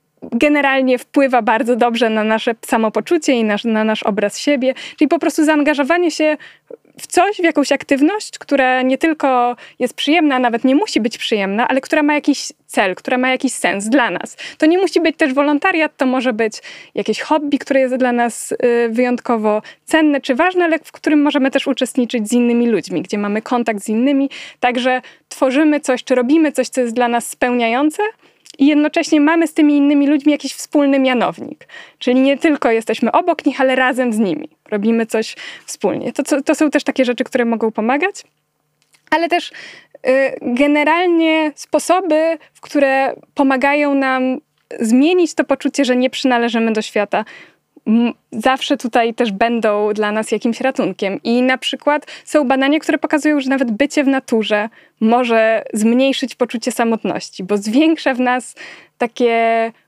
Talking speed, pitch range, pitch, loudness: 170 wpm, 235-300 Hz, 265 Hz, -16 LUFS